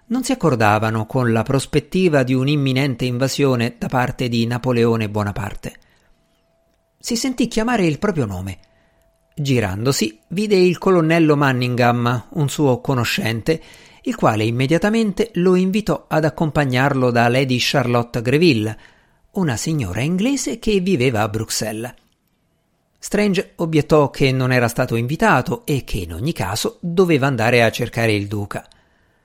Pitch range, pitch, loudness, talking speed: 115-165 Hz, 130 Hz, -18 LUFS, 130 wpm